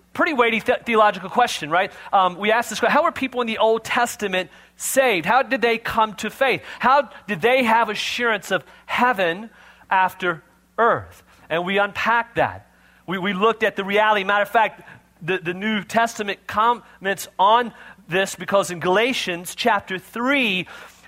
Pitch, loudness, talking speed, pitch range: 215 Hz, -20 LUFS, 170 wpm, 190-240 Hz